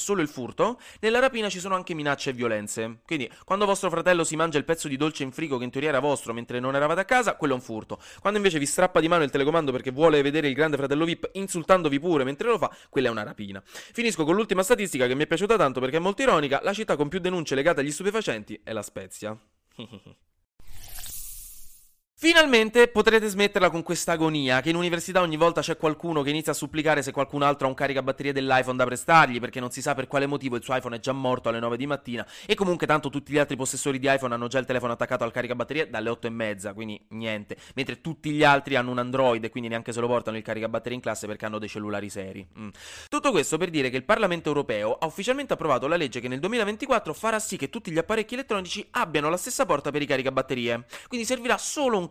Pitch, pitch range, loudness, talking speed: 145 Hz, 125-180 Hz, -25 LUFS, 240 wpm